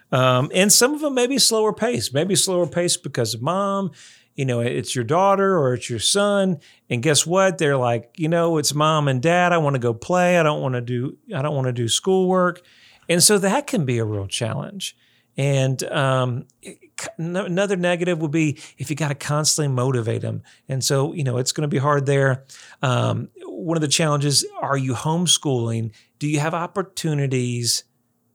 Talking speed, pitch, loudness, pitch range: 200 wpm, 150 Hz, -20 LUFS, 125-175 Hz